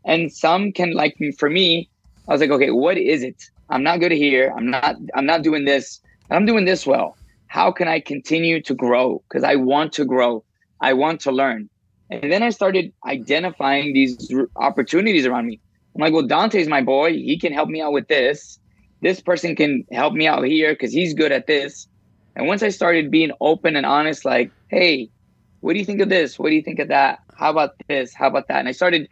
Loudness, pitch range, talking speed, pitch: -18 LUFS, 135-175 Hz, 225 wpm, 155 Hz